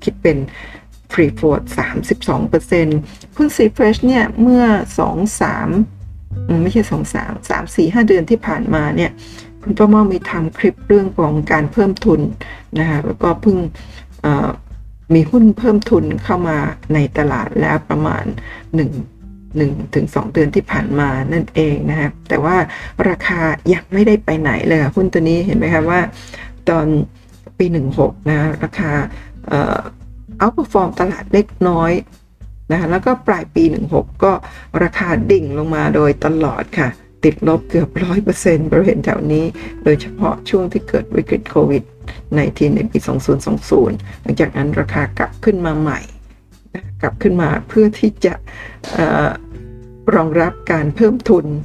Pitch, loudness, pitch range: 160 Hz, -15 LUFS, 135-190 Hz